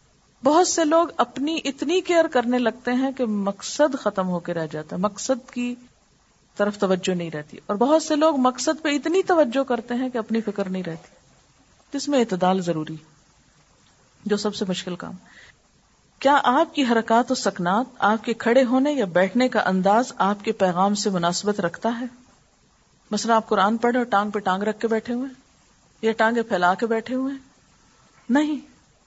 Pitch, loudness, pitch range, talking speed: 230 Hz, -22 LUFS, 200-265 Hz, 180 wpm